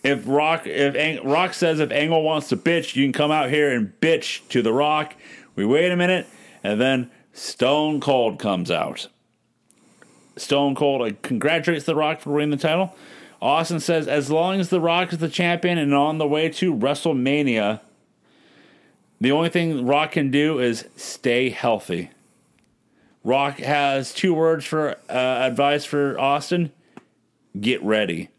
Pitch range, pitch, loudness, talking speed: 140-165 Hz, 150 Hz, -21 LUFS, 160 wpm